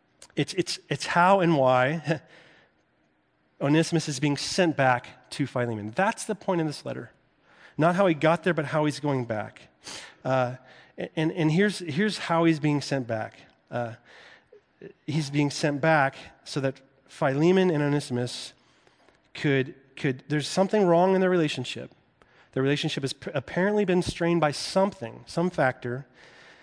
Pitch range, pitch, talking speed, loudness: 130-170 Hz, 150 Hz, 150 wpm, -26 LUFS